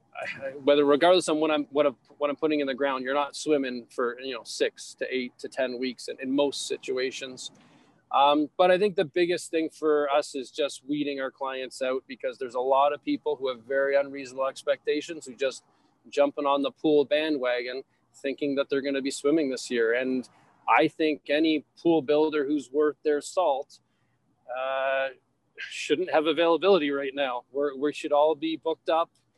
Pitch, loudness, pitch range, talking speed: 145 Hz, -27 LUFS, 135-155 Hz, 190 wpm